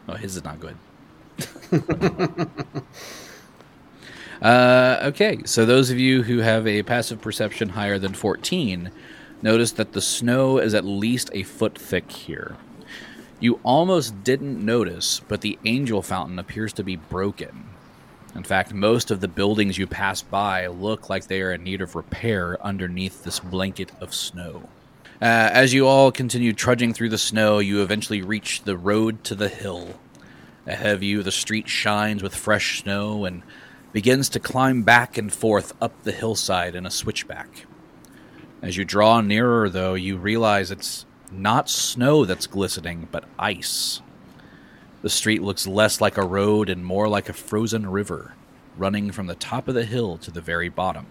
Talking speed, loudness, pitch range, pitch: 165 wpm, -22 LUFS, 95-120 Hz, 105 Hz